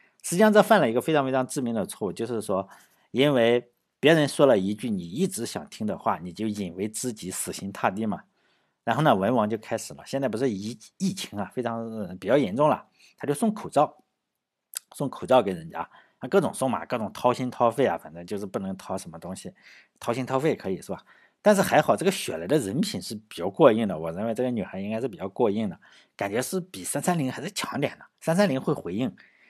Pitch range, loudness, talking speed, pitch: 115-180 Hz, -26 LUFS, 325 characters per minute, 130 Hz